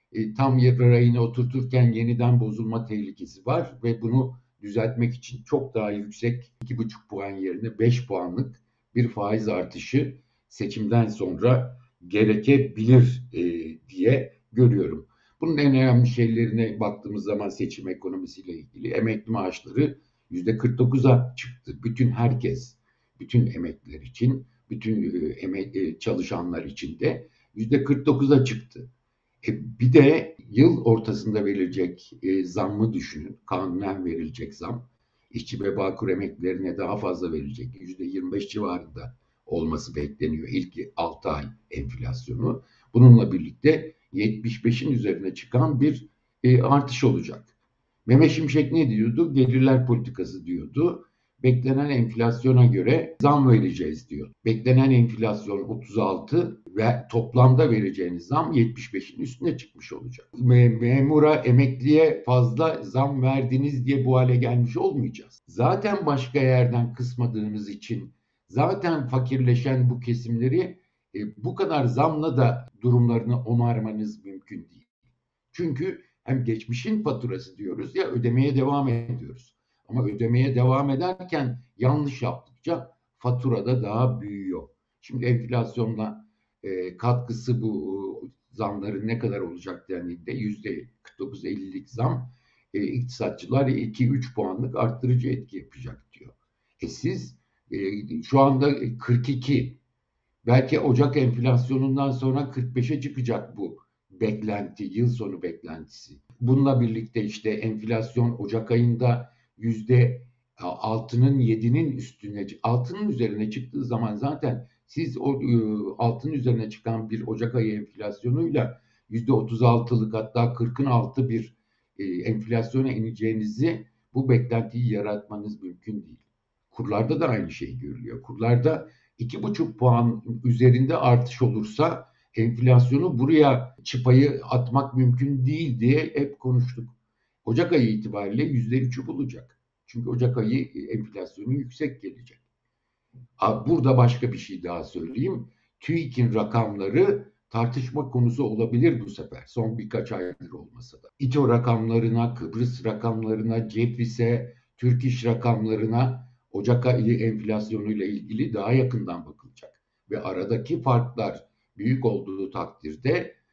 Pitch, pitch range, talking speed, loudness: 120 Hz, 115-130 Hz, 115 wpm, -24 LUFS